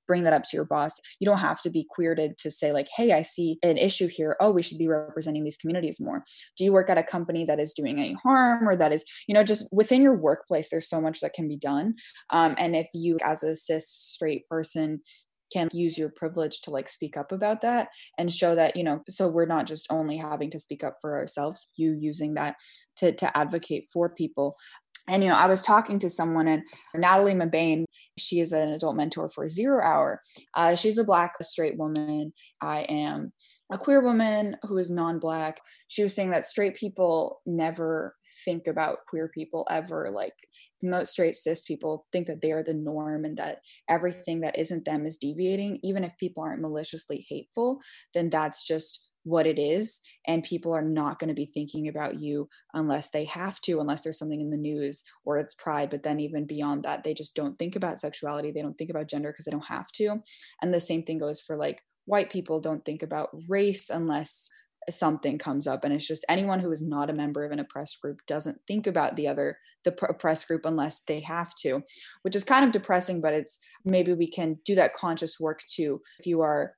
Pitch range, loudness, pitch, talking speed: 150-180 Hz, -27 LUFS, 160 Hz, 220 wpm